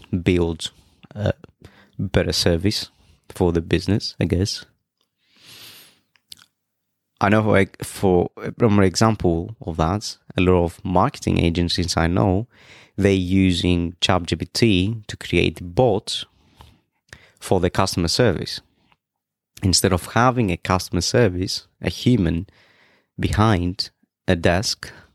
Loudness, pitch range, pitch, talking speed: -20 LUFS, 90-105 Hz, 95 Hz, 105 wpm